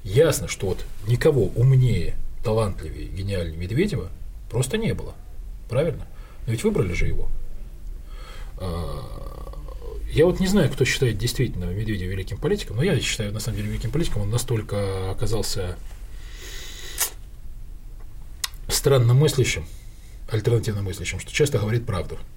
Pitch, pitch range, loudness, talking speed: 105 Hz, 90-120 Hz, -24 LUFS, 125 wpm